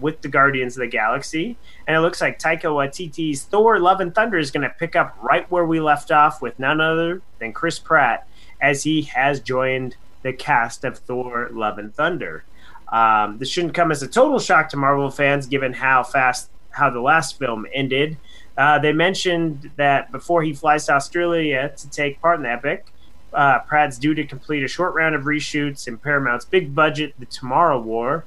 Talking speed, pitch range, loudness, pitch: 200 wpm, 135-160 Hz, -19 LUFS, 150 Hz